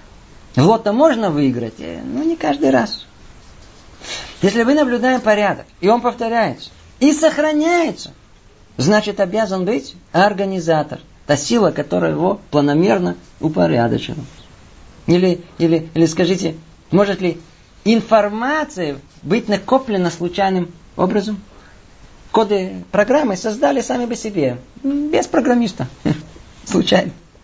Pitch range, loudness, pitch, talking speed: 165-230 Hz, -17 LUFS, 200 Hz, 100 wpm